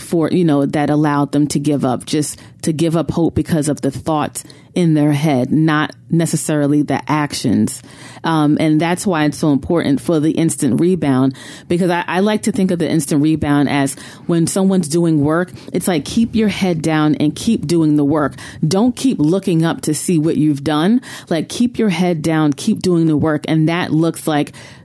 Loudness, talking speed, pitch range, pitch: -16 LUFS, 205 wpm, 150-175 Hz, 155 Hz